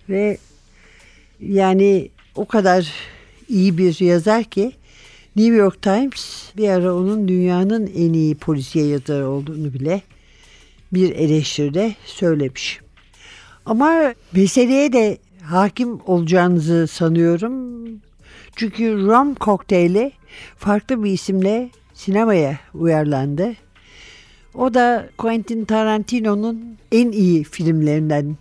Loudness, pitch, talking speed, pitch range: -18 LUFS, 195 Hz, 95 wpm, 165-220 Hz